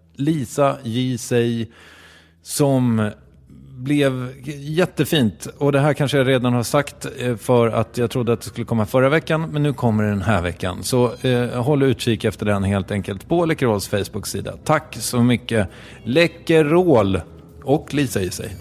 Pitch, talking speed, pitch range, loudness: 120 Hz, 160 wpm, 105-140 Hz, -20 LUFS